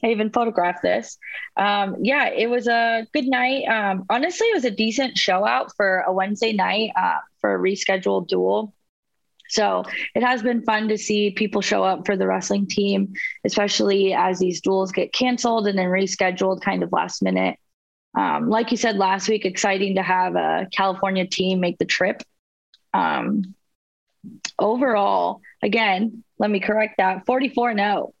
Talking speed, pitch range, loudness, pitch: 170 wpm, 190-230 Hz, -21 LUFS, 205 Hz